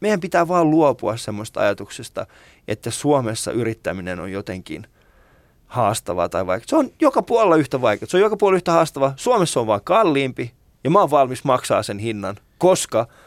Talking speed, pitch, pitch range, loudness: 170 wpm, 135 Hz, 110-175 Hz, -19 LUFS